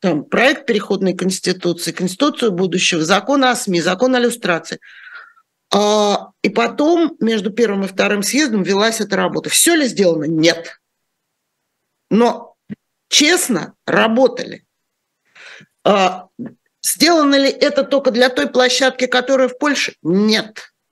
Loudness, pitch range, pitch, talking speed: -15 LUFS, 190-265 Hz, 230 Hz, 115 wpm